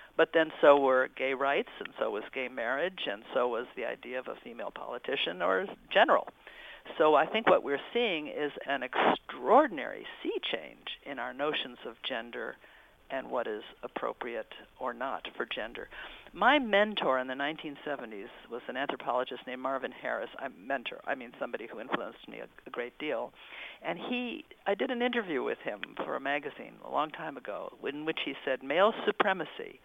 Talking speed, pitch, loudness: 180 wpm, 160 Hz, -32 LUFS